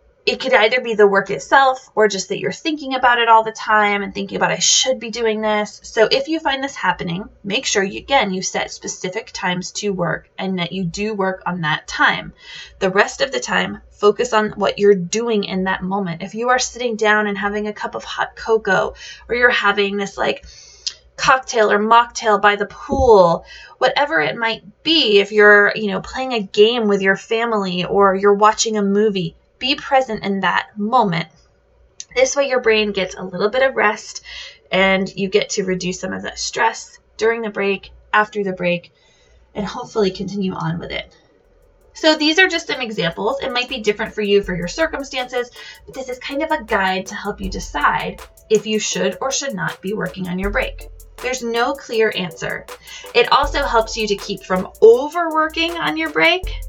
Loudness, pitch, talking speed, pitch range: -17 LUFS, 210 Hz, 205 wpm, 195-250 Hz